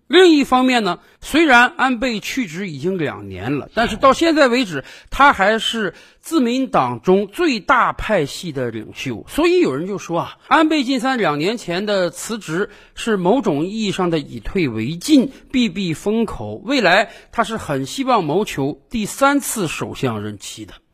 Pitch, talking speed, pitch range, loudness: 210 Hz, 245 characters per minute, 165-260 Hz, -18 LUFS